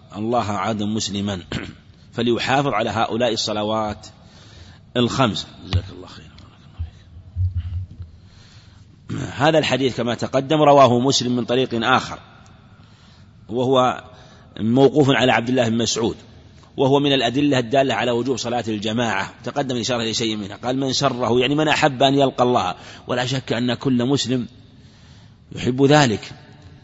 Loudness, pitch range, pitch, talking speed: -19 LUFS, 105-130 Hz, 120 Hz, 125 wpm